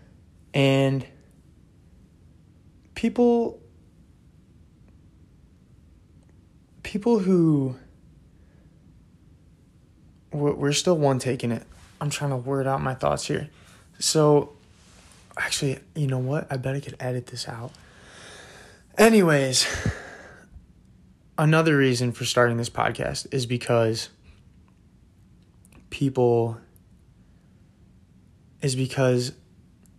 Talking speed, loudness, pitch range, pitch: 80 wpm, -24 LUFS, 100-145 Hz, 130 Hz